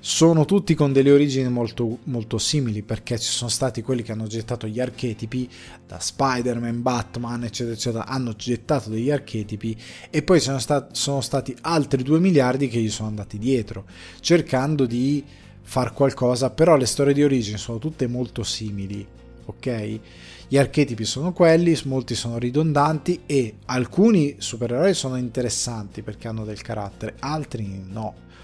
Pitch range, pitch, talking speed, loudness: 110-140 Hz, 125 Hz, 155 wpm, -22 LUFS